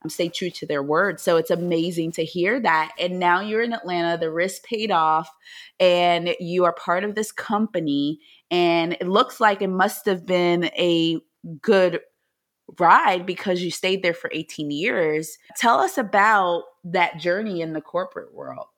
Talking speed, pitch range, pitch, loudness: 175 wpm, 165-190 Hz, 175 Hz, -21 LUFS